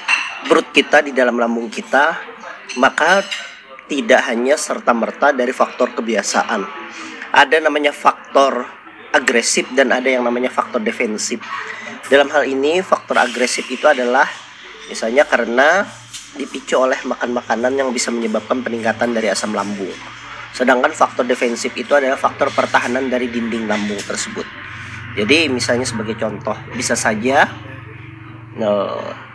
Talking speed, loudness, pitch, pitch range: 125 wpm, -16 LUFS, 120 Hz, 110-130 Hz